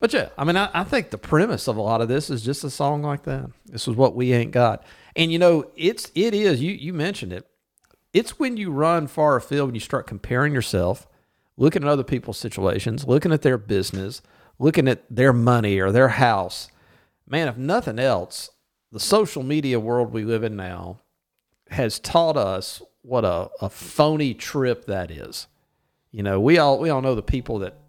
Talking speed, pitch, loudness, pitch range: 205 wpm, 130 Hz, -22 LUFS, 115-150 Hz